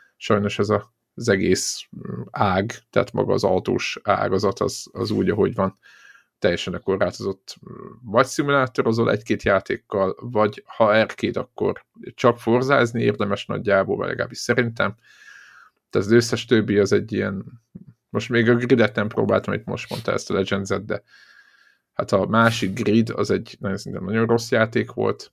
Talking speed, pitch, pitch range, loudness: 155 wpm, 115 Hz, 105-120 Hz, -22 LUFS